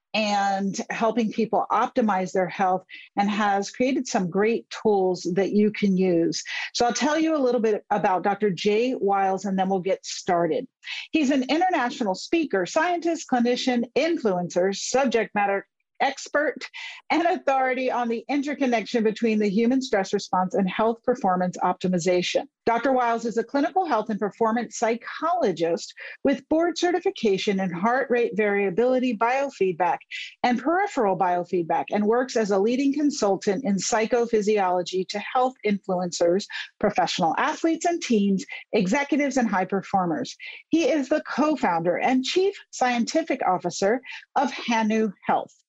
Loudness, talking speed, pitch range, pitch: -24 LUFS, 140 wpm, 195-270 Hz, 225 Hz